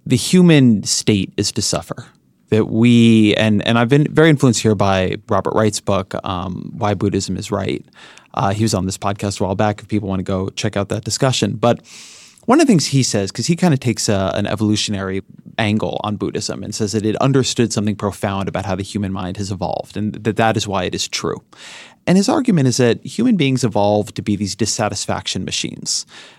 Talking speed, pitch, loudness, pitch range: 215 wpm, 105 Hz, -17 LUFS, 100-120 Hz